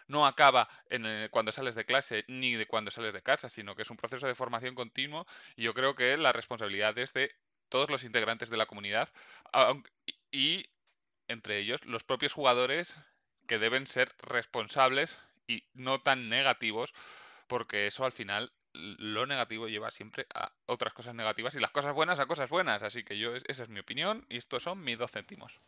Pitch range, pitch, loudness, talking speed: 110-130 Hz, 125 Hz, -32 LUFS, 195 wpm